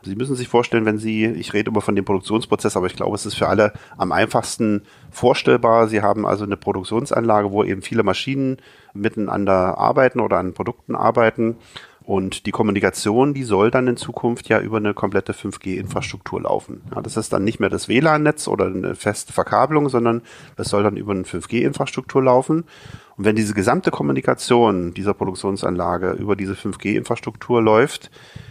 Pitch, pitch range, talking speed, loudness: 110 Hz, 100-120 Hz, 170 wpm, -19 LUFS